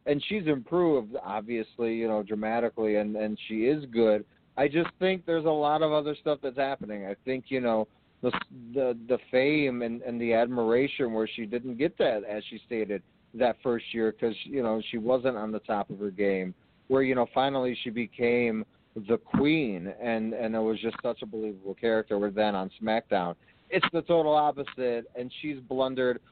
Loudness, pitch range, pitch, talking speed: -29 LUFS, 110-130 Hz, 115 Hz, 195 wpm